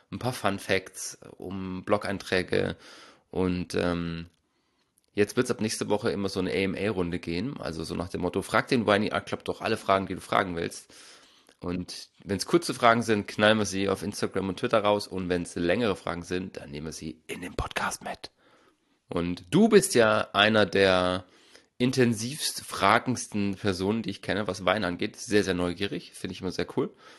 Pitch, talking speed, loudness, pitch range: 95 Hz, 190 wpm, -27 LUFS, 90-110 Hz